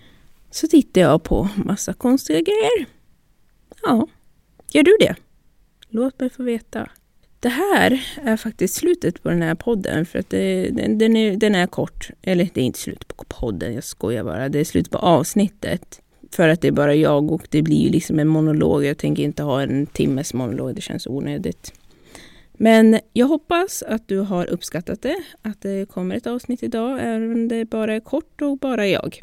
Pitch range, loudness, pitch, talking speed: 165-250 Hz, -20 LUFS, 220 Hz, 195 wpm